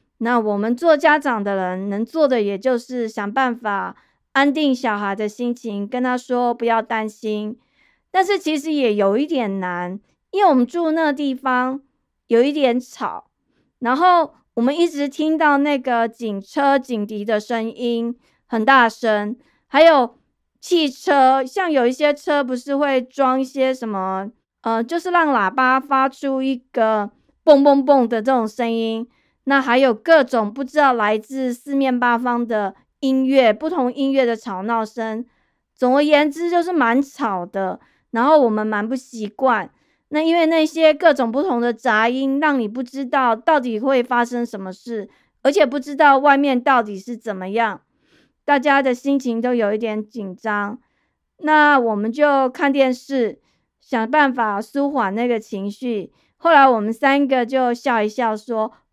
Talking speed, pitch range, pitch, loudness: 230 characters per minute, 225-280 Hz, 250 Hz, -18 LUFS